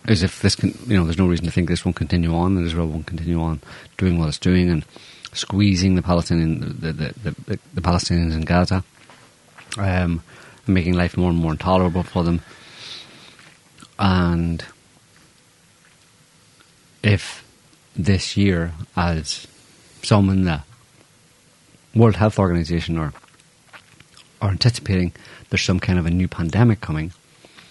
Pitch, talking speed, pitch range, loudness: 90 Hz, 145 wpm, 85-100 Hz, -20 LUFS